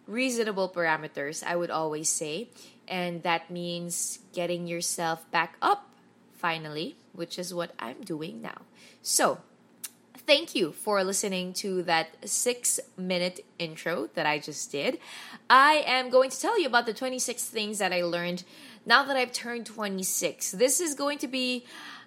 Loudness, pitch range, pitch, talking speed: -28 LUFS, 170-250 Hz, 190 Hz, 155 wpm